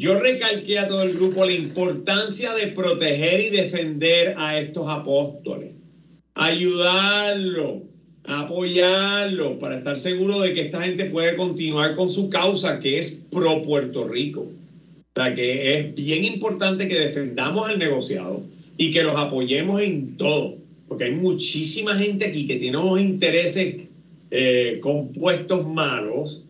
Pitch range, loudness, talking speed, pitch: 155-190 Hz, -21 LUFS, 140 wpm, 170 Hz